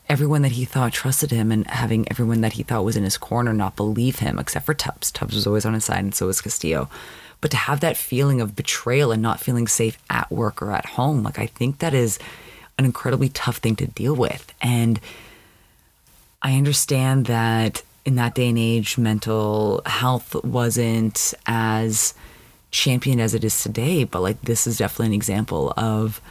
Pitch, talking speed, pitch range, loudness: 115 Hz, 195 wpm, 110-130 Hz, -21 LUFS